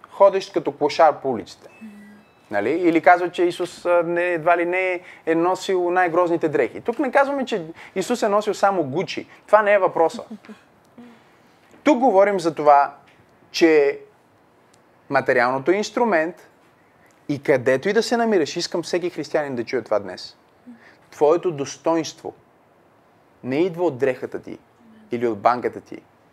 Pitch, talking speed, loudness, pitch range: 180 Hz, 140 wpm, -20 LUFS, 165-215 Hz